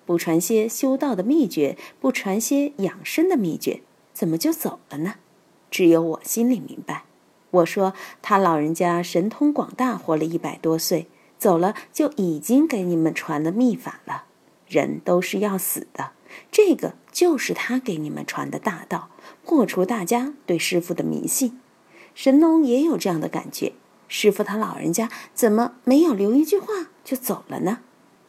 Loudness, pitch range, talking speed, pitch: -22 LUFS, 175-275 Hz, 240 characters per minute, 215 Hz